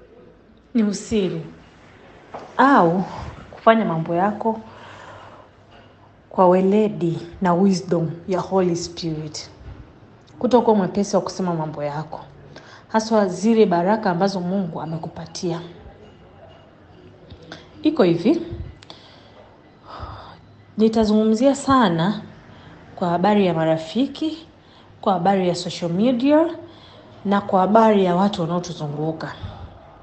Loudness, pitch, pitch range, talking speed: -20 LUFS, 185 Hz, 165-215 Hz, 90 wpm